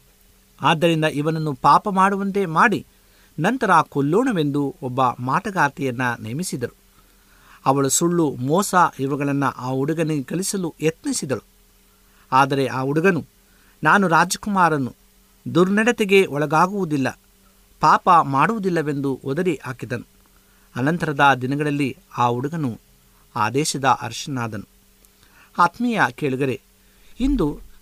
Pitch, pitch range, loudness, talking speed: 145 Hz, 130-170 Hz, -20 LUFS, 85 wpm